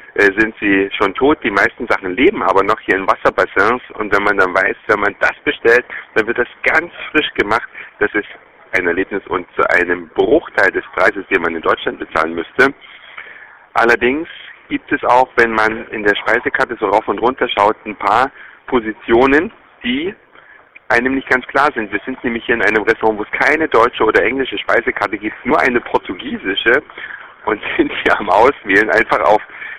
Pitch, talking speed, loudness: 120 Hz, 185 wpm, -15 LUFS